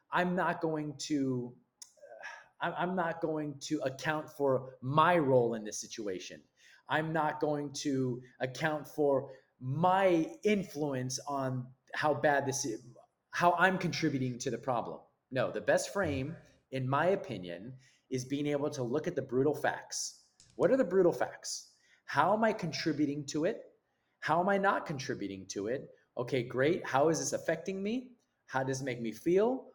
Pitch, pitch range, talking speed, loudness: 150 Hz, 130-170 Hz, 165 wpm, -33 LUFS